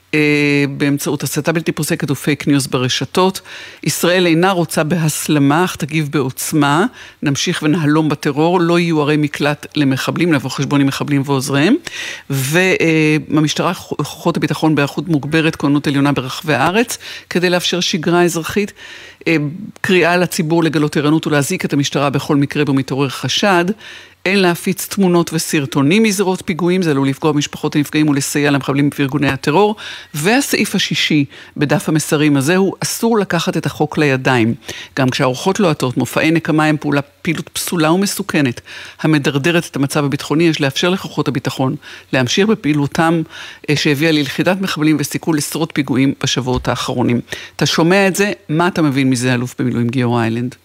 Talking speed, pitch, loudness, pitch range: 140 wpm, 155 Hz, -15 LUFS, 140-170 Hz